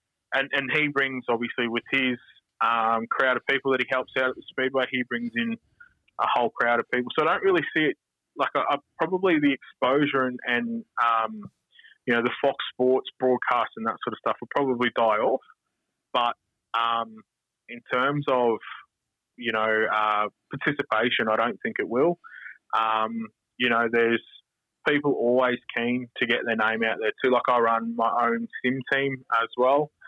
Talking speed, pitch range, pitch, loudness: 185 wpm, 115-130 Hz, 125 Hz, -25 LUFS